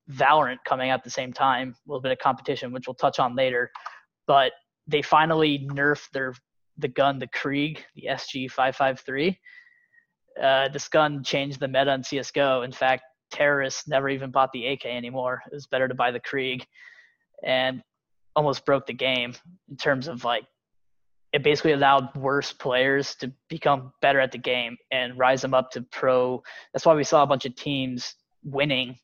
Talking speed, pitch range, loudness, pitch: 185 wpm, 130-145 Hz, -24 LUFS, 135 Hz